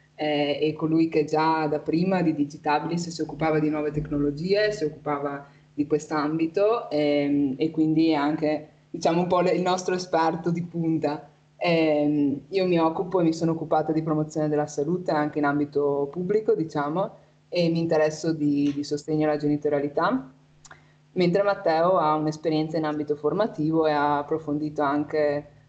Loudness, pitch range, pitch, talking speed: -25 LUFS, 150-165 Hz, 155 Hz, 160 wpm